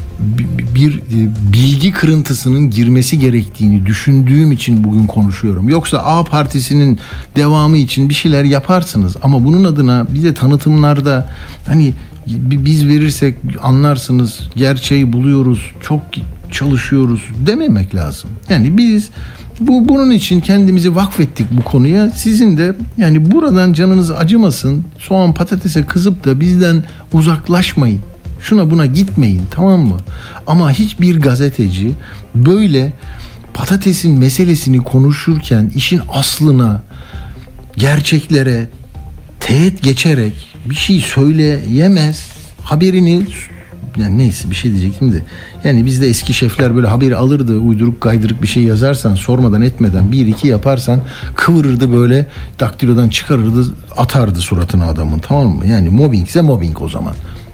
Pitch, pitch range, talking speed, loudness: 135 Hz, 115-155 Hz, 120 wpm, -11 LUFS